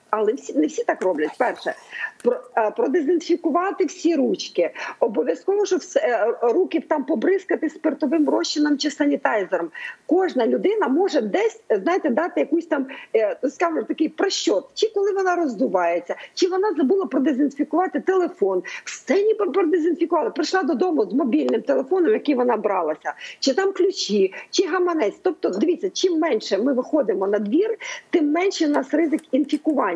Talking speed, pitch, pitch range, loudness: 145 wpm, 325 Hz, 280-370 Hz, -22 LUFS